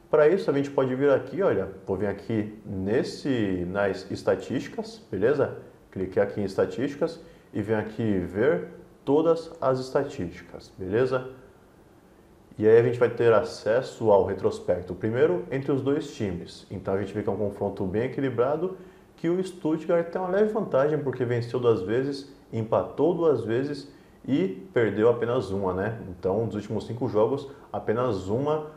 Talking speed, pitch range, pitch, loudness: 155 wpm, 105-165 Hz, 130 Hz, -26 LUFS